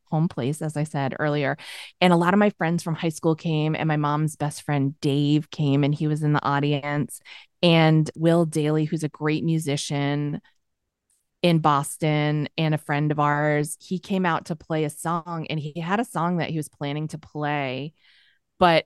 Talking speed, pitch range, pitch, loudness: 195 wpm, 145-165 Hz, 155 Hz, -24 LUFS